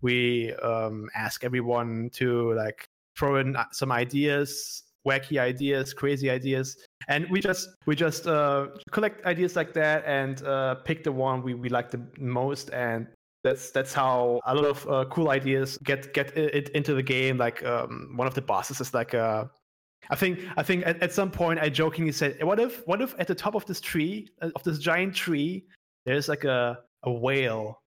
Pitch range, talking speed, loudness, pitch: 125-160 Hz, 190 wpm, -27 LUFS, 140 Hz